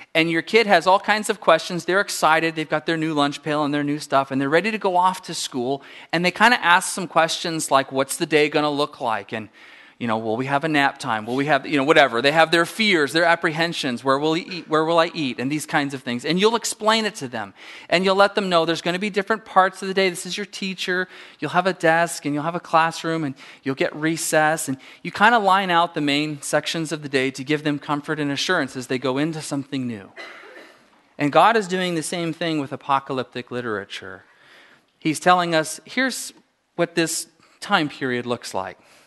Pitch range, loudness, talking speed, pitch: 140-180 Hz, -21 LUFS, 245 wpm, 160 Hz